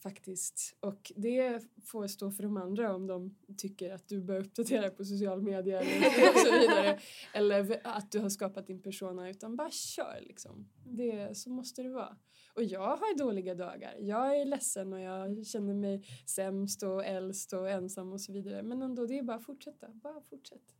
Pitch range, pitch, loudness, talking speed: 190-230 Hz, 200 Hz, -34 LUFS, 195 wpm